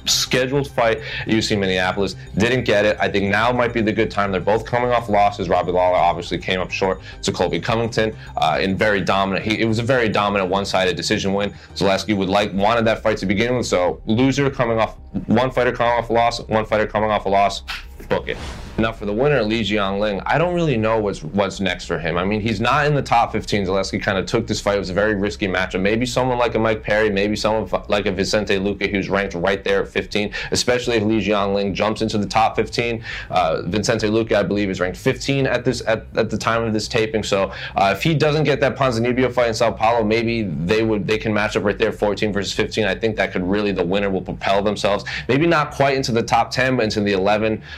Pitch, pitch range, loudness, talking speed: 110 Hz, 100-115 Hz, -19 LUFS, 245 wpm